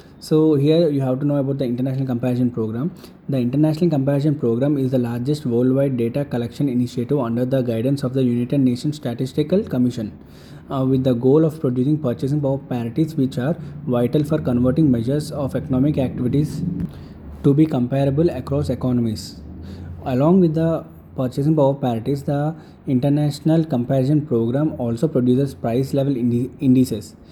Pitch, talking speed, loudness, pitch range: 135 Hz, 155 wpm, -20 LUFS, 125-145 Hz